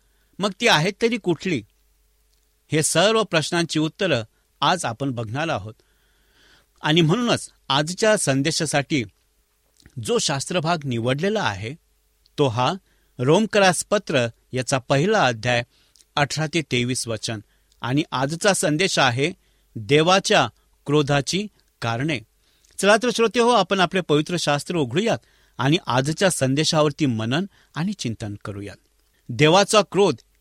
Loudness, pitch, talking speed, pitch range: -21 LUFS, 150 Hz, 110 wpm, 120-180 Hz